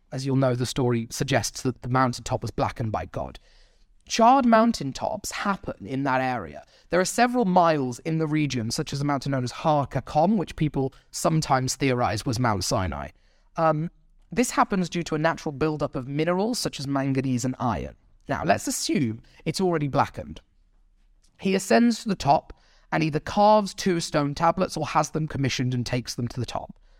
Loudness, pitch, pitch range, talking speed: -25 LUFS, 140 Hz, 125-170 Hz, 180 wpm